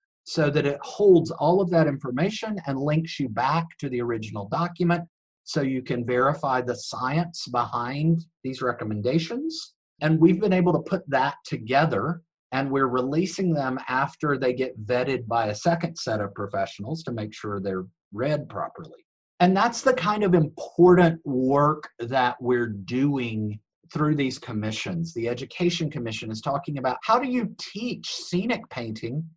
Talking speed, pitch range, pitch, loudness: 160 wpm, 125-170 Hz, 145 Hz, -25 LUFS